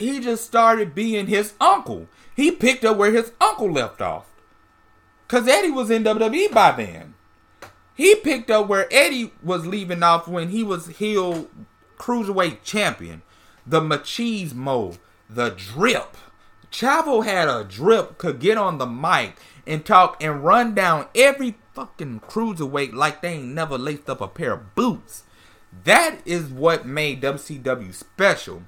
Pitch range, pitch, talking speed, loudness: 145-230 Hz, 185 Hz, 150 wpm, -20 LUFS